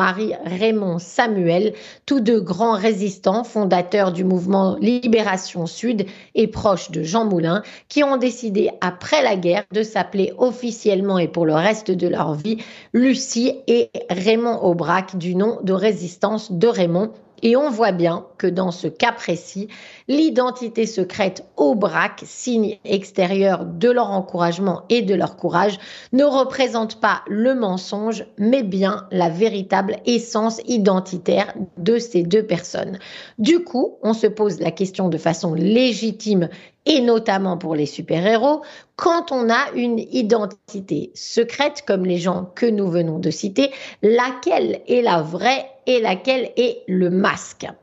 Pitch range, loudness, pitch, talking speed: 185-235 Hz, -19 LUFS, 210 Hz, 150 wpm